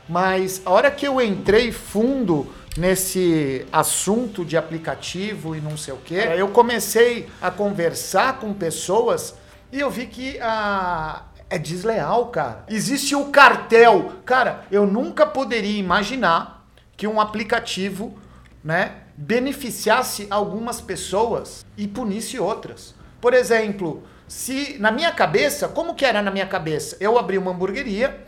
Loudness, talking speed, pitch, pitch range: -20 LUFS, 135 wpm, 210 Hz, 185-240 Hz